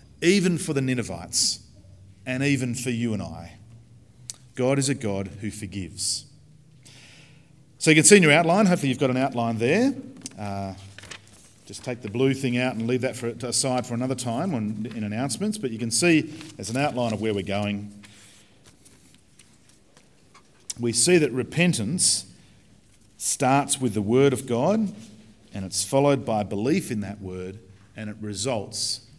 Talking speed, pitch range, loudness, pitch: 160 wpm, 105-140 Hz, -23 LUFS, 120 Hz